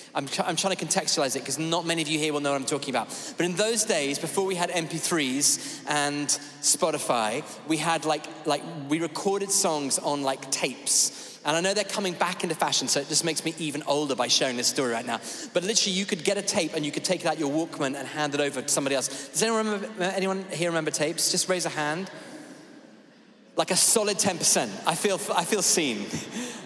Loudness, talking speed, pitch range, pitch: -25 LUFS, 230 wpm, 145-190 Hz, 165 Hz